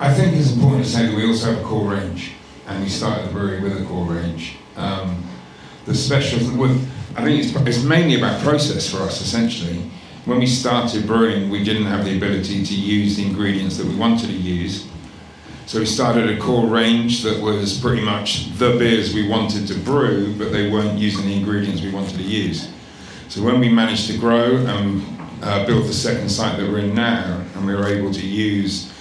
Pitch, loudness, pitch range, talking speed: 105 Hz, -19 LUFS, 100-115 Hz, 210 wpm